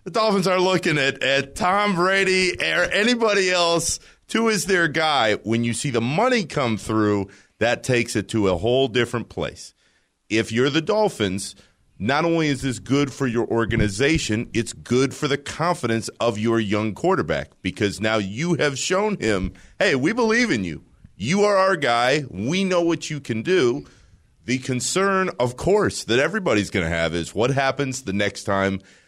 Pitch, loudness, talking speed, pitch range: 130 Hz, -21 LUFS, 180 wpm, 110-175 Hz